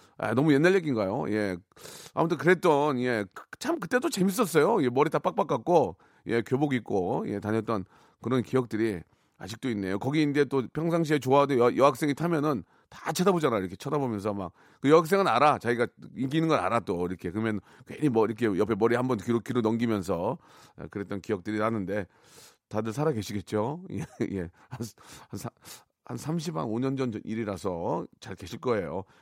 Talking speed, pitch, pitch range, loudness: 350 characters per minute, 120 Hz, 105-150 Hz, -27 LUFS